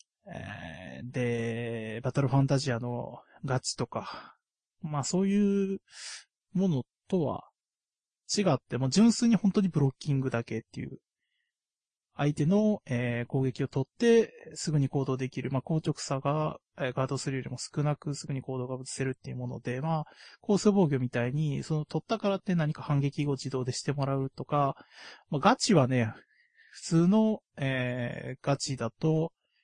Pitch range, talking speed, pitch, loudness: 130-170 Hz, 295 characters per minute, 140 Hz, -30 LUFS